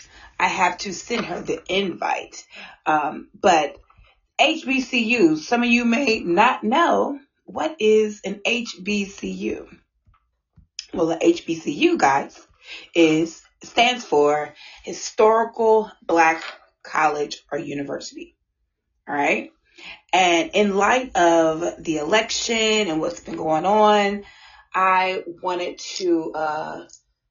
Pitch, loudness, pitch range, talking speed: 210 Hz, -20 LUFS, 175-250 Hz, 110 wpm